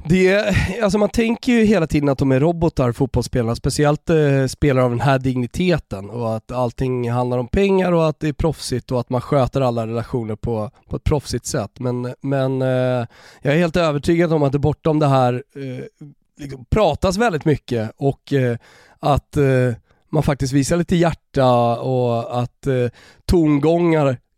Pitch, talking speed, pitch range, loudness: 135 Hz, 175 wpm, 125-155 Hz, -19 LUFS